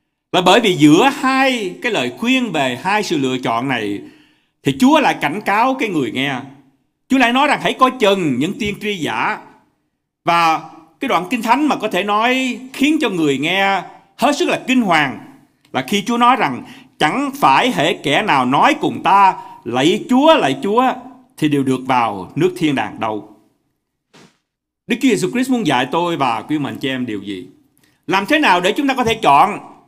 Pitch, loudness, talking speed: 215 Hz, -16 LUFS, 195 wpm